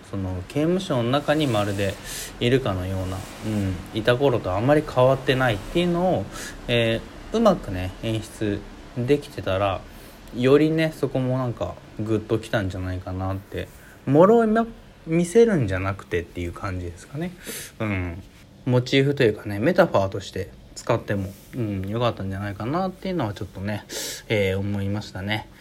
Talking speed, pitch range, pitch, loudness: 305 characters per minute, 95-135 Hz, 105 Hz, -24 LUFS